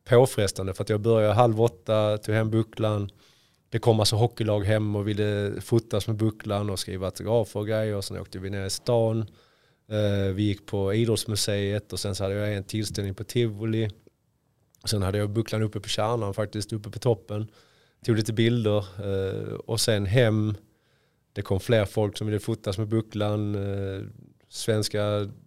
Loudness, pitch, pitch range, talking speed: -26 LUFS, 105 Hz, 100-115 Hz, 170 wpm